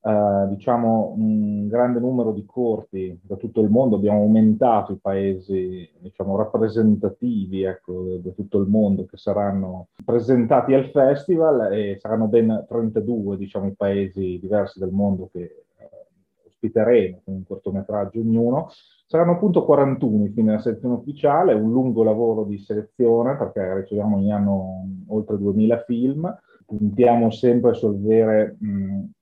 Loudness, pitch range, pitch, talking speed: -21 LUFS, 100-120 Hz, 110 Hz, 140 wpm